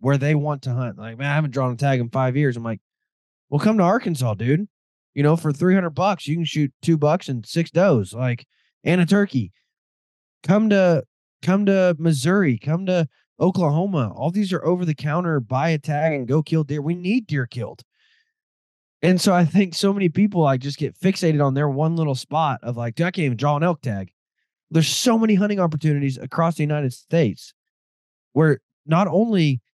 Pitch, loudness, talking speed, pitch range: 155 Hz, -21 LUFS, 205 wpm, 135-175 Hz